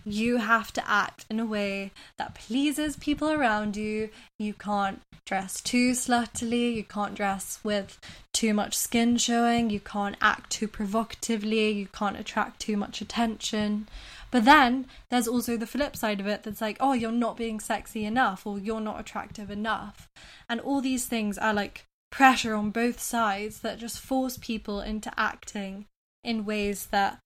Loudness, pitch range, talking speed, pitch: -27 LUFS, 210-235 Hz, 170 wpm, 220 Hz